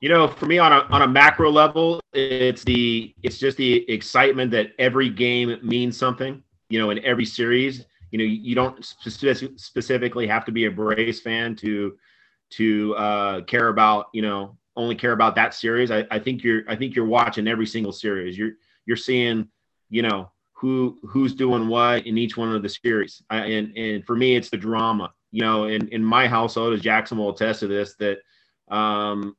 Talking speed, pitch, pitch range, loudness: 200 wpm, 115 Hz, 110-125 Hz, -21 LUFS